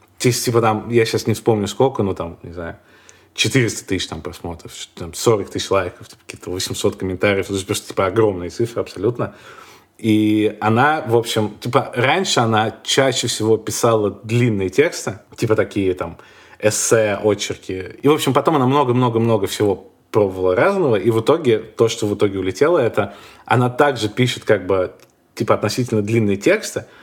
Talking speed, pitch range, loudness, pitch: 160 wpm, 105-125 Hz, -18 LUFS, 110 Hz